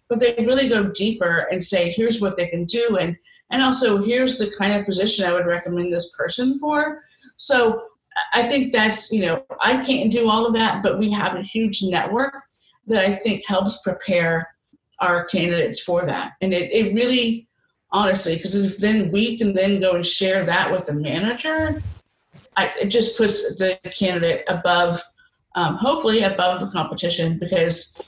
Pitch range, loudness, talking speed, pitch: 180-235 Hz, -20 LUFS, 175 wpm, 200 Hz